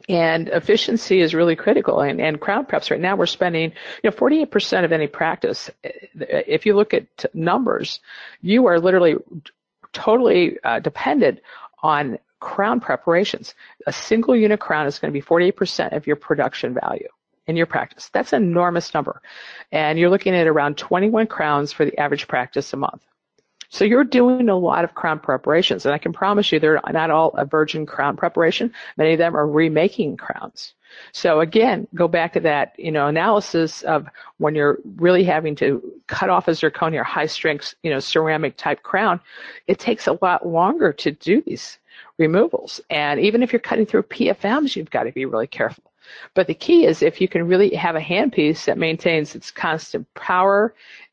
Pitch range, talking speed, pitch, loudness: 155-205 Hz, 185 wpm, 170 Hz, -19 LUFS